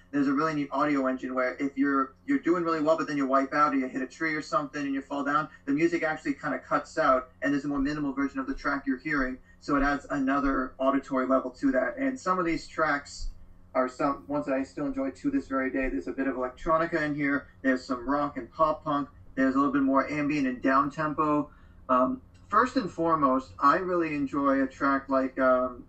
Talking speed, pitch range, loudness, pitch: 240 wpm, 130-165 Hz, -28 LUFS, 140 Hz